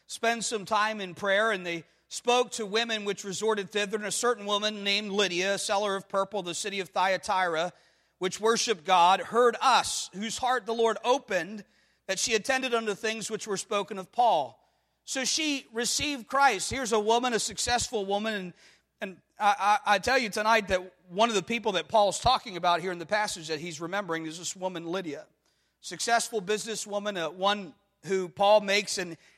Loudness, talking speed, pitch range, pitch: -27 LUFS, 190 wpm, 190-225 Hz, 205 Hz